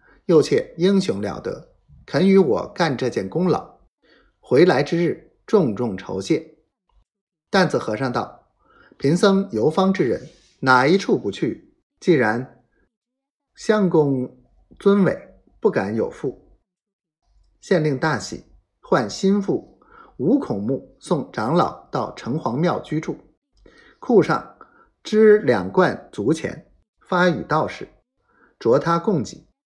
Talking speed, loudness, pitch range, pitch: 165 characters per minute, -20 LUFS, 160-205 Hz, 190 Hz